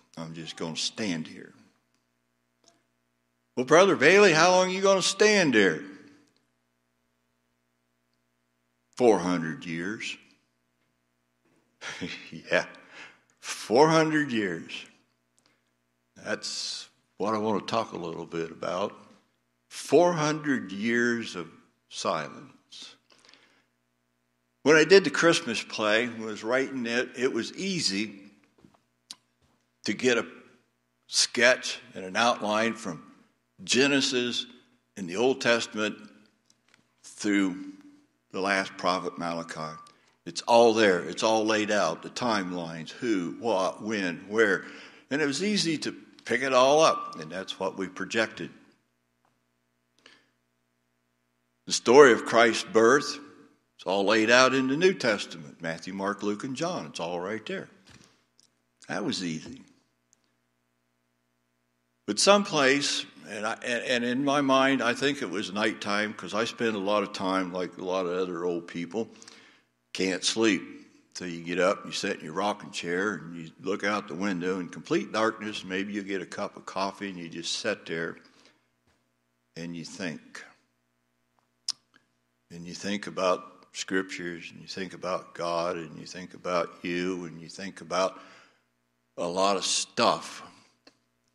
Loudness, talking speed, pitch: -26 LUFS, 135 wpm, 85 Hz